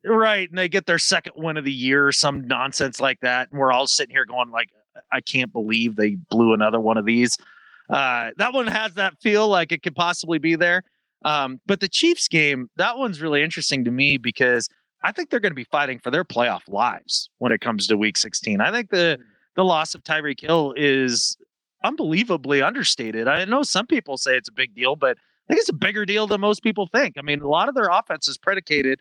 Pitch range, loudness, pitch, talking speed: 125-190 Hz, -21 LUFS, 150 Hz, 230 wpm